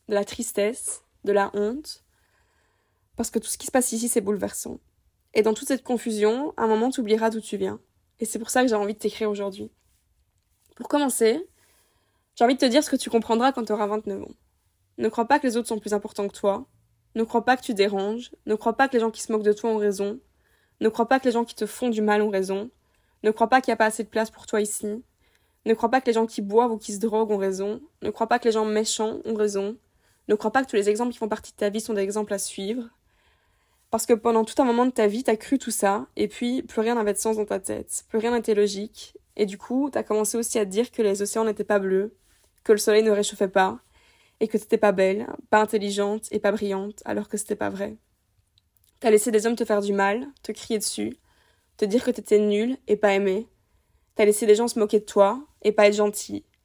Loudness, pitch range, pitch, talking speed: -24 LUFS, 205-230 Hz, 215 Hz, 260 wpm